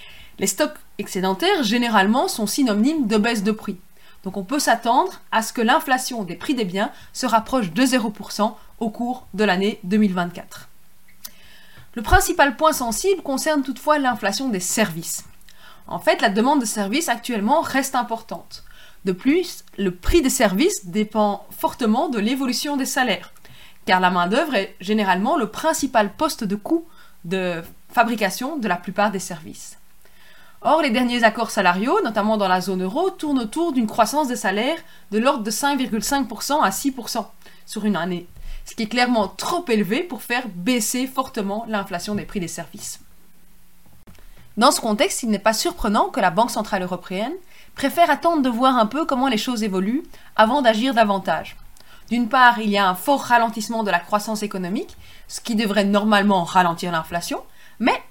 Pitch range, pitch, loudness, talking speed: 205-270 Hz, 225 Hz, -21 LUFS, 165 wpm